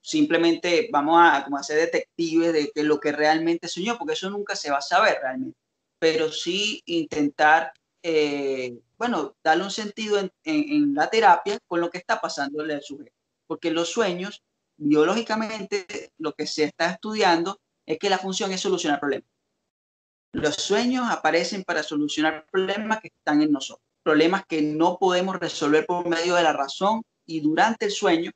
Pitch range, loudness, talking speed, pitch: 150-205 Hz, -23 LUFS, 170 wpm, 170 Hz